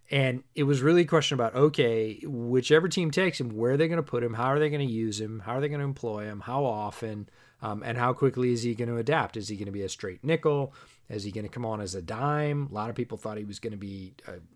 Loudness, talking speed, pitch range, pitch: -28 LUFS, 295 wpm, 110-145 Hz, 120 Hz